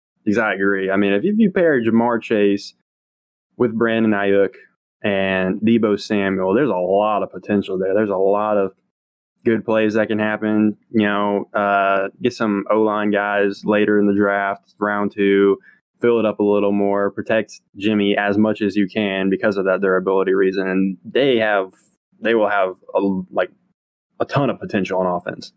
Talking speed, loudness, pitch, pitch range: 180 wpm, -18 LUFS, 100 Hz, 95-110 Hz